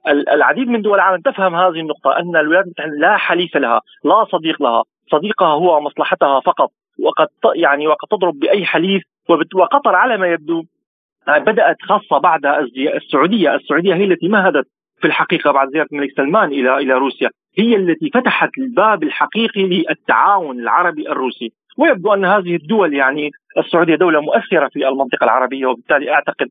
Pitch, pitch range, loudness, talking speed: 170 Hz, 145-205 Hz, -15 LUFS, 155 wpm